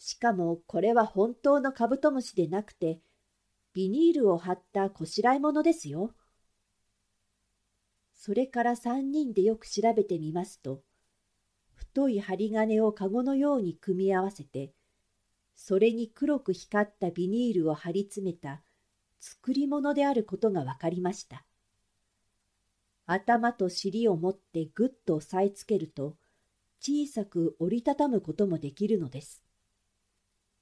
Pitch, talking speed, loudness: 185 Hz, 265 characters per minute, -29 LUFS